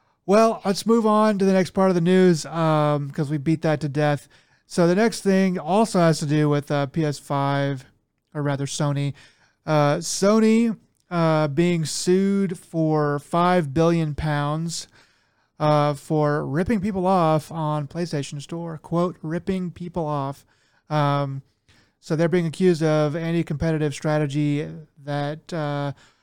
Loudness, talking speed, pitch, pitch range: -22 LUFS, 145 wpm, 155 Hz, 145-180 Hz